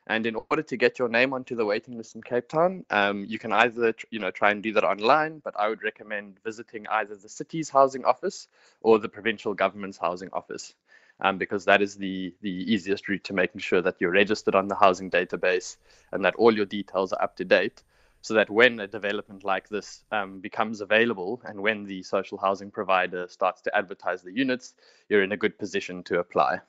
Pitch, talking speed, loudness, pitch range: 105 Hz, 220 wpm, -26 LUFS, 100-120 Hz